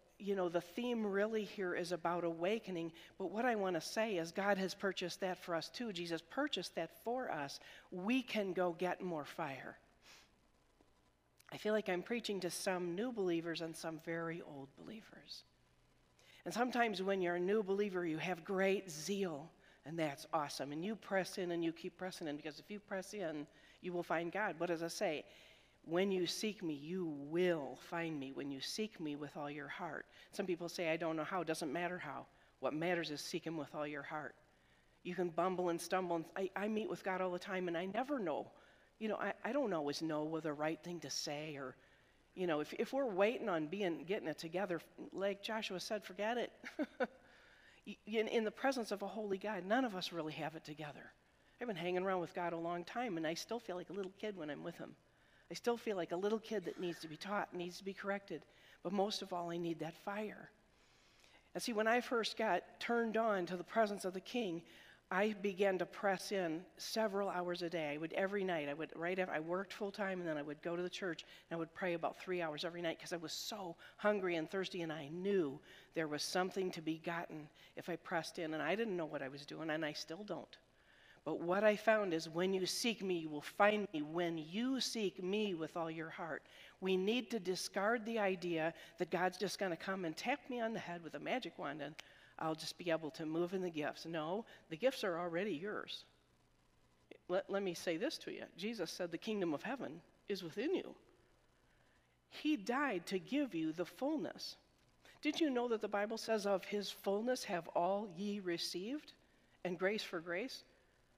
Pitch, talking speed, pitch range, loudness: 180 Hz, 225 wpm, 165-205 Hz, -41 LUFS